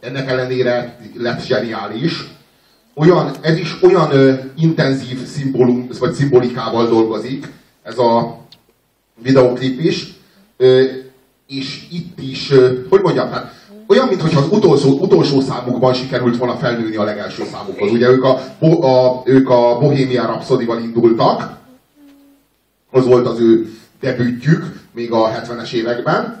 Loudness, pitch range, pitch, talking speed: -15 LUFS, 120-155 Hz, 130 Hz, 125 wpm